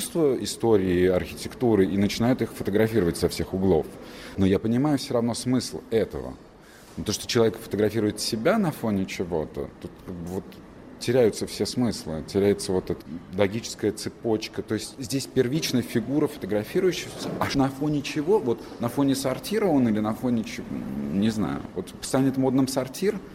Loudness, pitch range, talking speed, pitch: -25 LUFS, 100-130 Hz, 150 wpm, 110 Hz